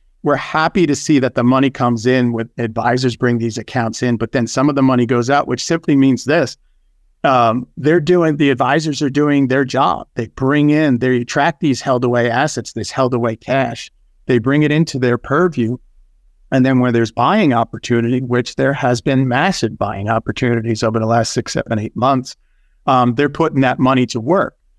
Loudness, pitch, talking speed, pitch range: -16 LUFS, 125 Hz, 200 wpm, 115-140 Hz